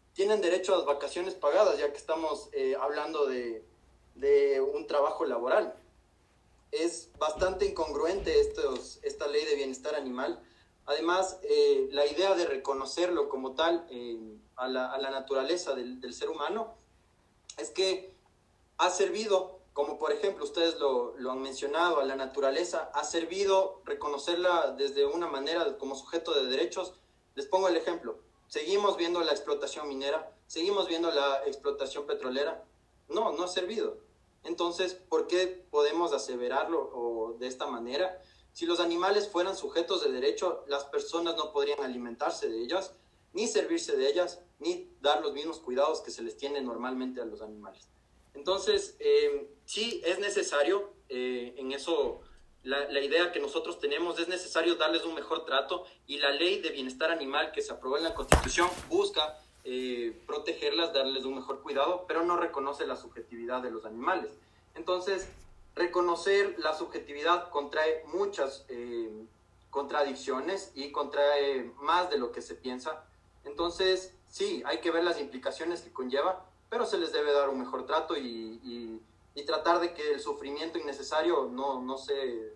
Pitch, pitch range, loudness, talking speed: 170 Hz, 135-200 Hz, -31 LUFS, 160 wpm